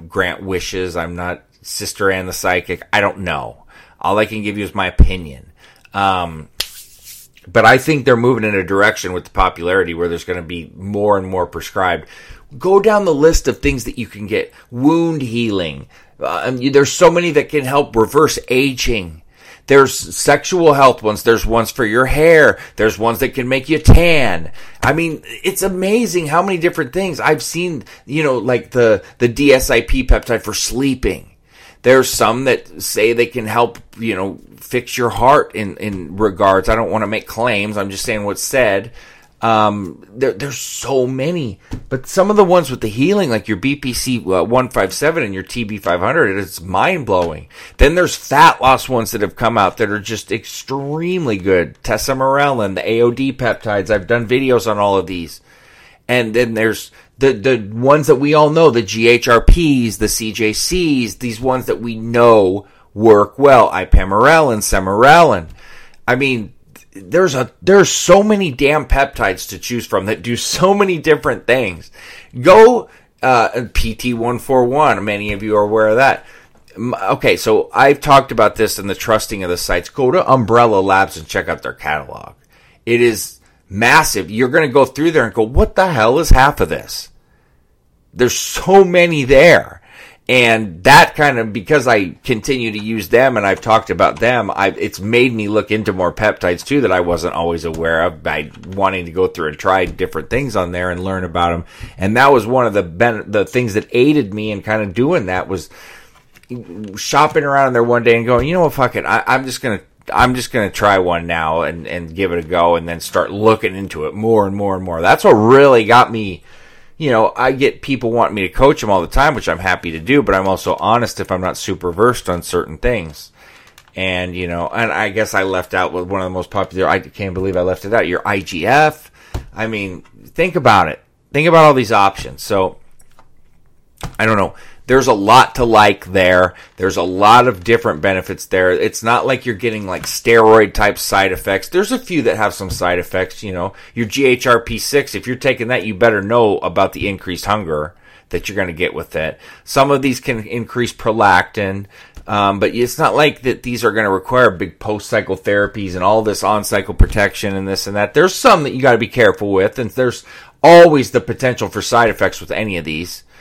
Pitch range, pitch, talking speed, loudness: 95-130 Hz, 110 Hz, 200 wpm, -14 LUFS